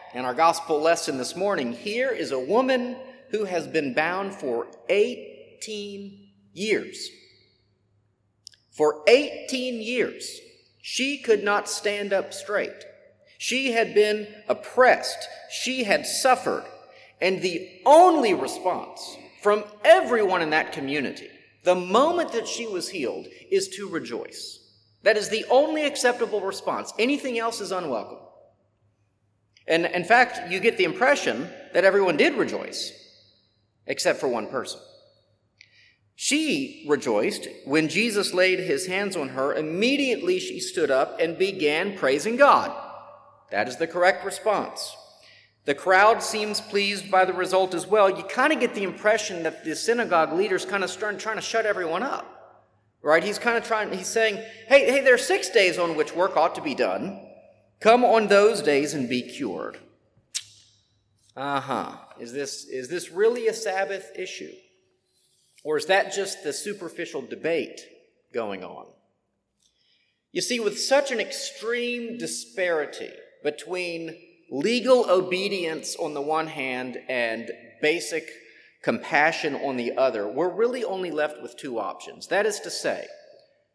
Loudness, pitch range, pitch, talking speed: -24 LUFS, 165-255 Hz, 205 Hz, 145 wpm